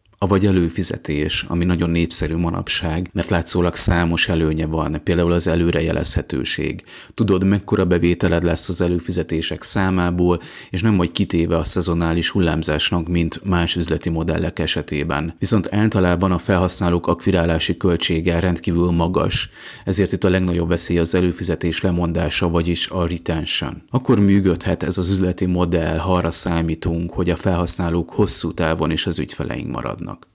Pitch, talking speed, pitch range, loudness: 85 Hz, 140 wpm, 85-95 Hz, -19 LUFS